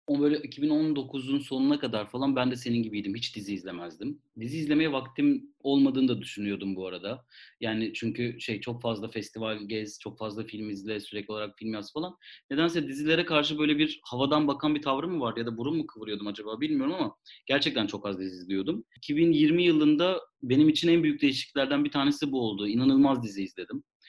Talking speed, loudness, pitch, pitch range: 185 wpm, -28 LUFS, 130 Hz, 110-150 Hz